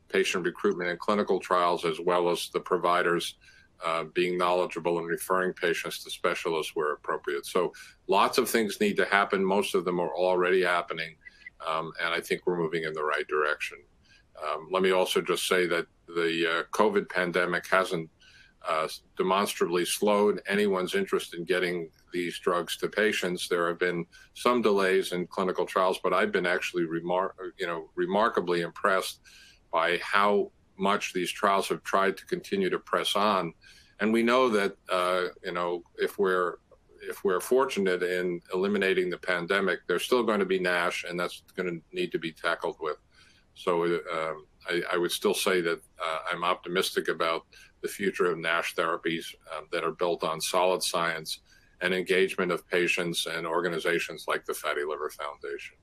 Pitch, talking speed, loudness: 90 Hz, 175 wpm, -28 LUFS